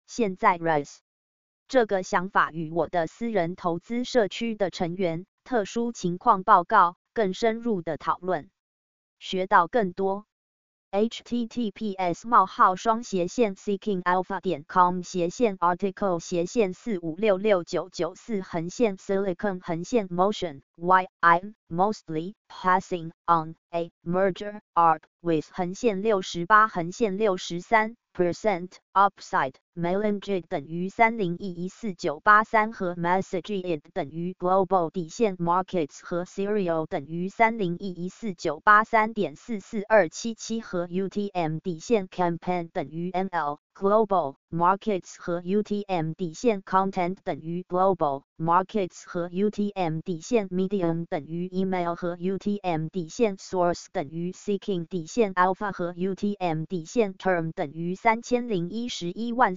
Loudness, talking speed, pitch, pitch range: -26 LUFS, 155 wpm, 185 Hz, 175-210 Hz